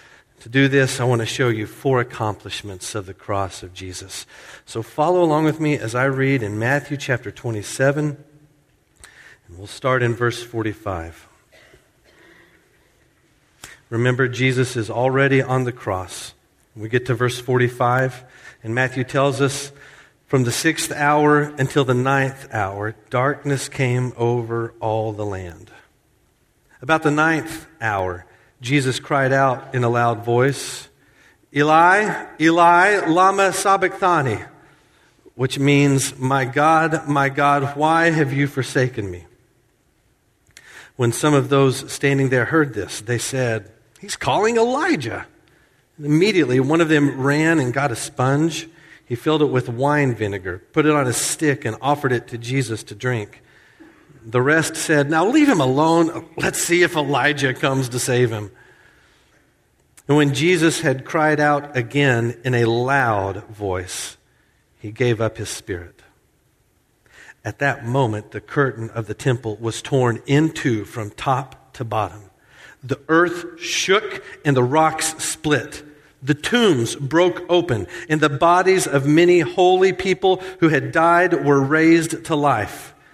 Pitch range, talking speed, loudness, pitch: 120-155 Hz, 145 wpm, -19 LUFS, 135 Hz